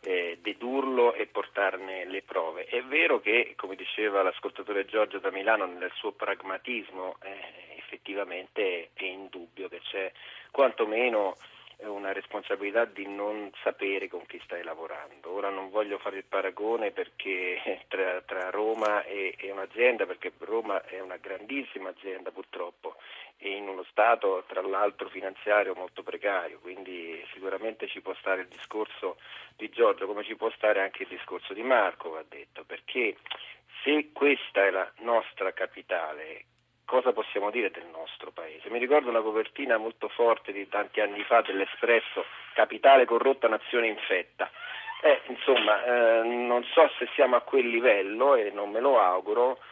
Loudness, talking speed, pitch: -28 LUFS, 150 wpm, 135 Hz